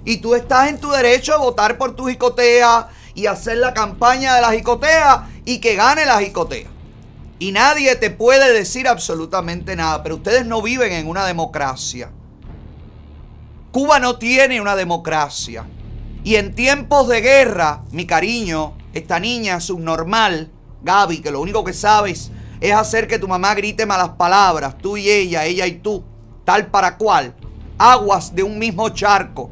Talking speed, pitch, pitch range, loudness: 165 wpm, 205 Hz, 160-240 Hz, -15 LUFS